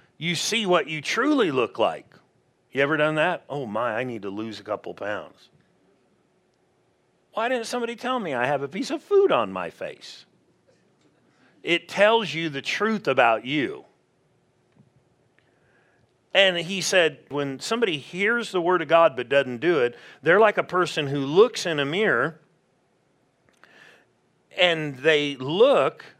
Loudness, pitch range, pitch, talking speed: -23 LUFS, 145-220 Hz, 175 Hz, 155 wpm